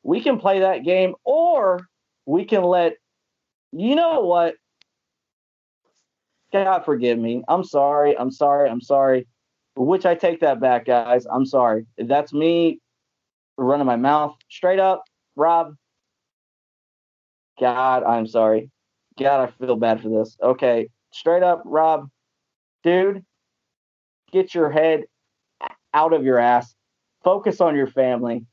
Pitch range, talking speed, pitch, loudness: 125-180 Hz, 130 wpm, 145 Hz, -20 LUFS